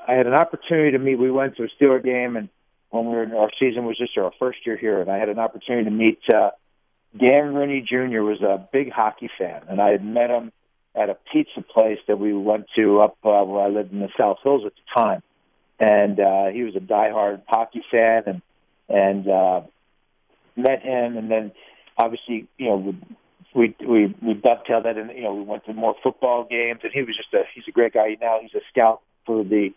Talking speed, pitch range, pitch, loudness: 230 wpm, 105-125 Hz, 115 Hz, -21 LUFS